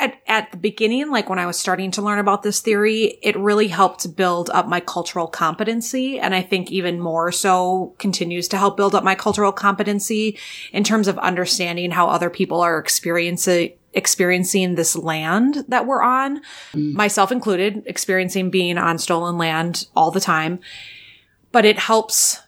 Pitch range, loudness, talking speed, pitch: 175-210 Hz, -19 LUFS, 170 wpm, 190 Hz